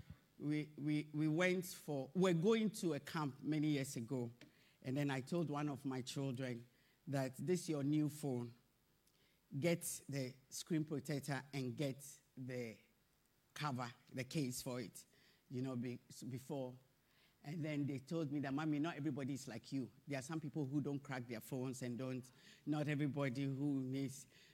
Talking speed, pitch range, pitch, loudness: 175 wpm, 130-150 Hz, 140 Hz, -43 LUFS